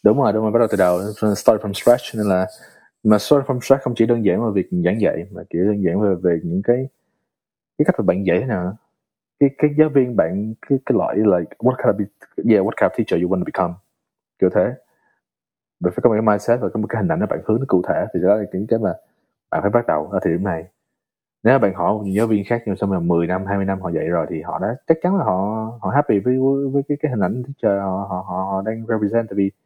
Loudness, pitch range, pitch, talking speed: -19 LUFS, 95-120 Hz, 105 Hz, 285 wpm